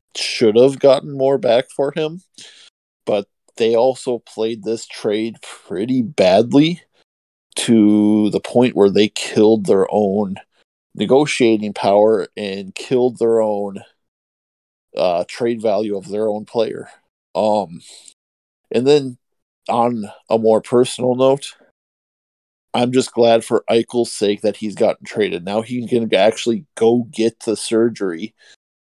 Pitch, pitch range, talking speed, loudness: 115 Hz, 105-125 Hz, 130 wpm, -17 LUFS